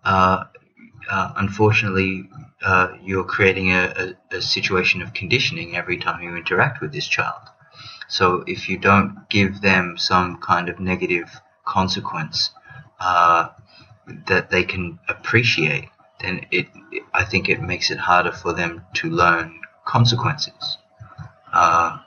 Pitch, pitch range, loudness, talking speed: 95 Hz, 90-105 Hz, -19 LUFS, 135 wpm